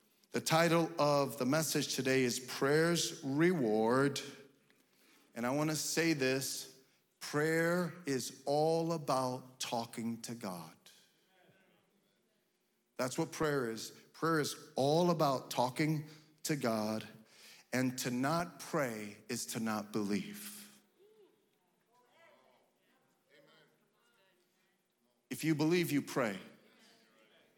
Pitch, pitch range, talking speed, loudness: 145 Hz, 125-165 Hz, 100 wpm, -35 LUFS